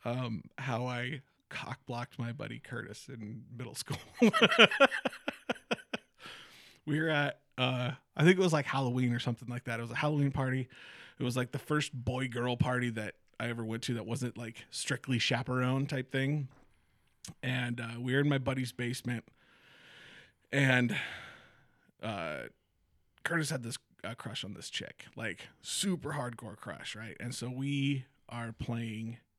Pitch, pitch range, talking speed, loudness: 125 Hz, 120-140 Hz, 160 wpm, -33 LUFS